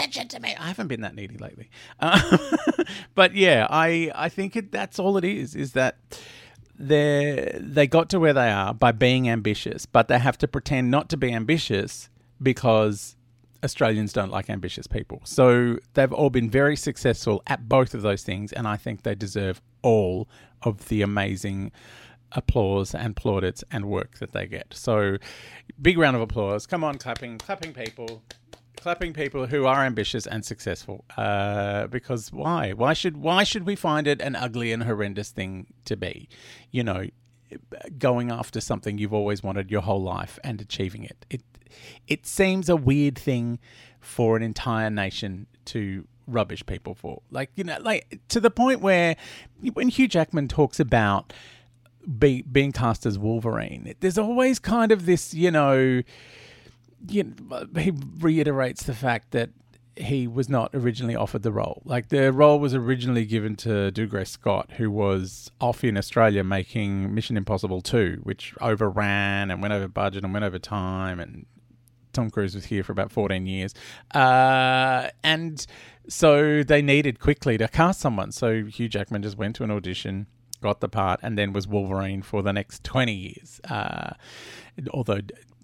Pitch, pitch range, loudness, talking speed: 120 Hz, 105-140 Hz, -24 LUFS, 170 wpm